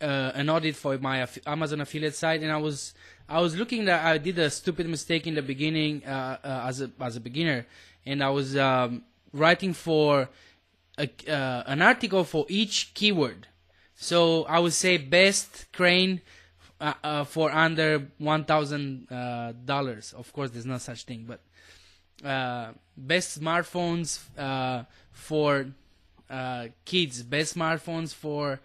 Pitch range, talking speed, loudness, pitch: 130-160 Hz, 155 wpm, -26 LUFS, 145 Hz